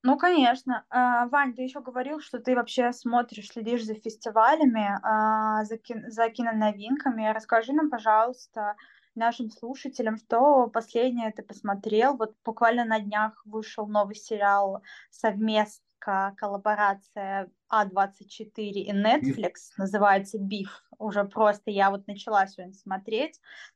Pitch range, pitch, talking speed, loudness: 205-240 Hz, 220 Hz, 120 wpm, -26 LUFS